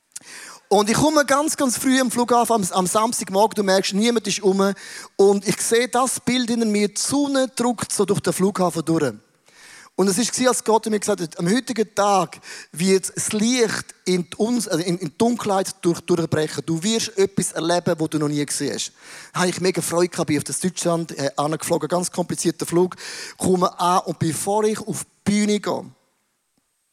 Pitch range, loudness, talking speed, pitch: 170-220 Hz, -21 LUFS, 190 wpm, 190 Hz